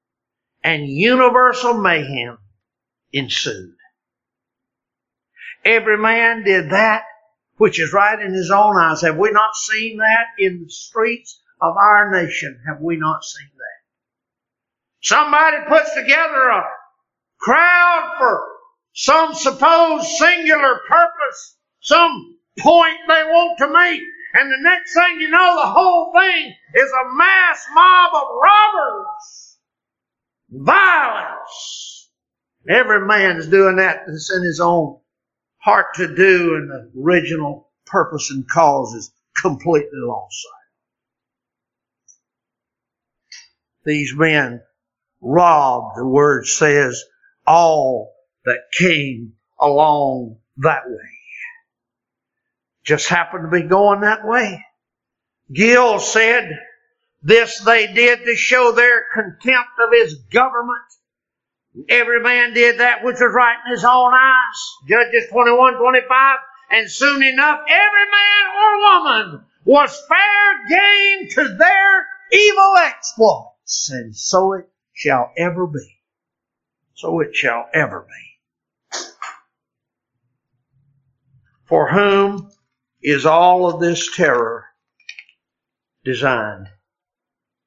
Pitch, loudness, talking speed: 230 Hz, -14 LUFS, 115 wpm